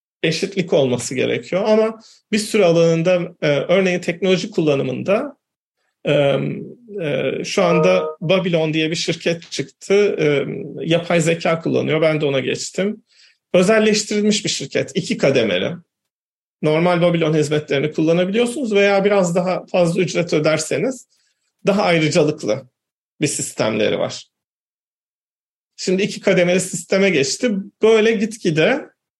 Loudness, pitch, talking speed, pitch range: -18 LUFS, 180 Hz, 105 wpm, 155-200 Hz